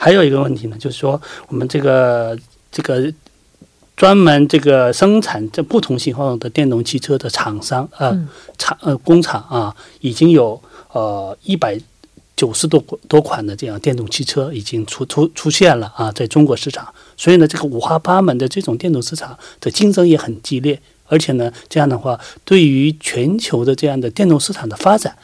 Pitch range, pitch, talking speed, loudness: 120-160 Hz, 140 Hz, 280 characters per minute, -15 LUFS